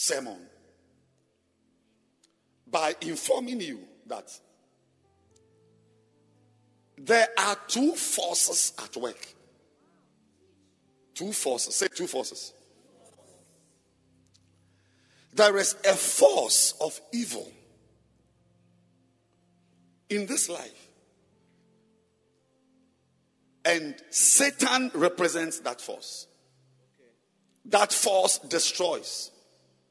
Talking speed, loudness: 65 wpm, -25 LUFS